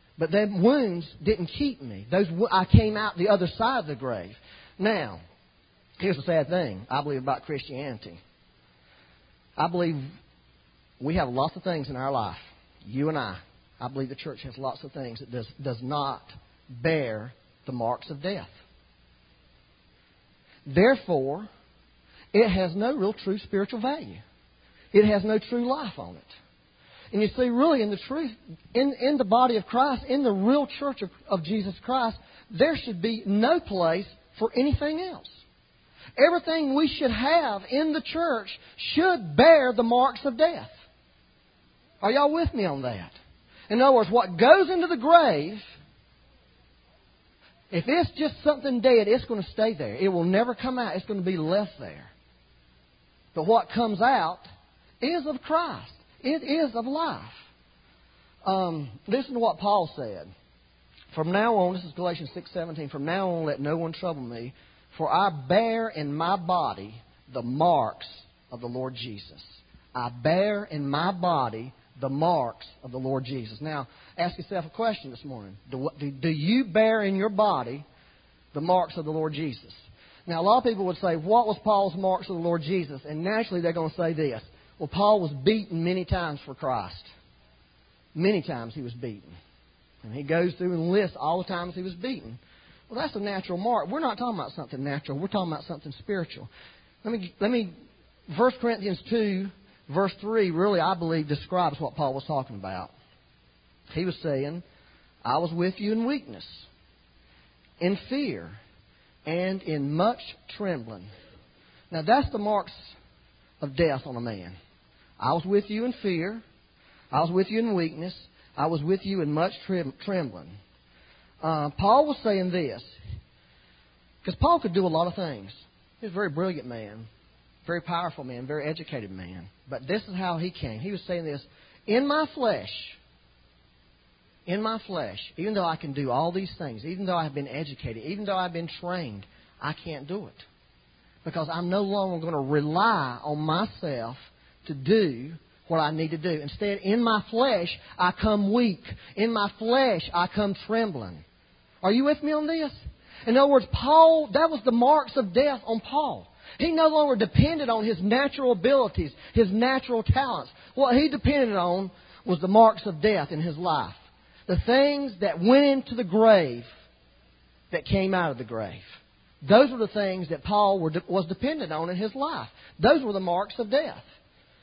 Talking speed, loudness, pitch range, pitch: 175 wpm, -26 LUFS, 135-220 Hz, 180 Hz